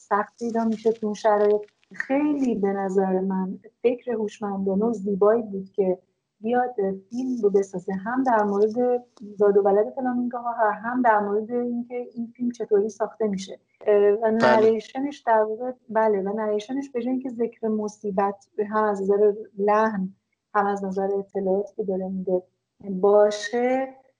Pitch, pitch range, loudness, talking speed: 215 Hz, 200-235 Hz, -24 LUFS, 145 wpm